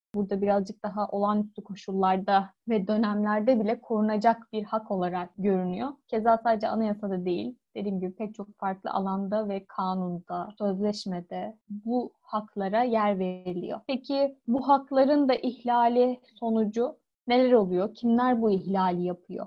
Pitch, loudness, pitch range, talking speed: 210 Hz, -27 LUFS, 195-235 Hz, 130 wpm